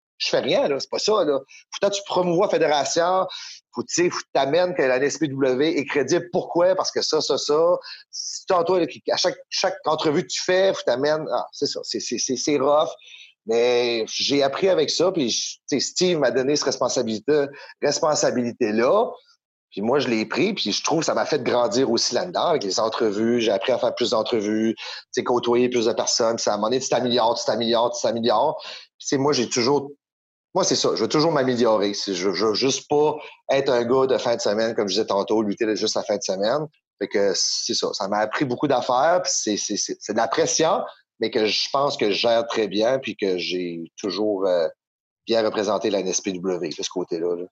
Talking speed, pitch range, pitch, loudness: 220 wpm, 115-185 Hz, 140 Hz, -22 LUFS